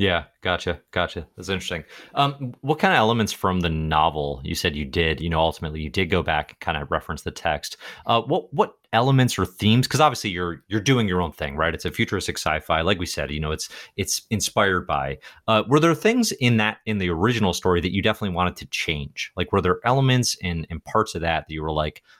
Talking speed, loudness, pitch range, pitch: 235 wpm, -23 LUFS, 80-110 Hz, 90 Hz